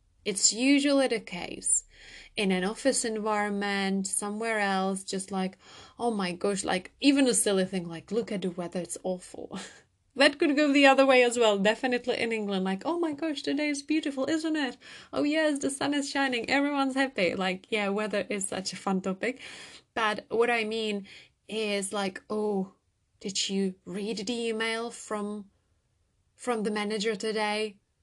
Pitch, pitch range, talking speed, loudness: 215 Hz, 195-260 Hz, 170 wpm, -28 LUFS